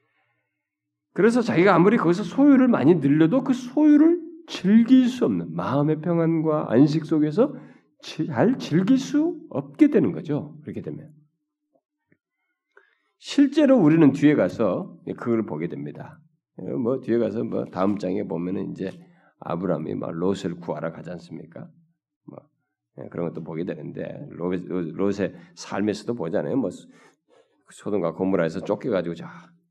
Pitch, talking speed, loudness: 155 Hz, 280 characters per minute, -22 LUFS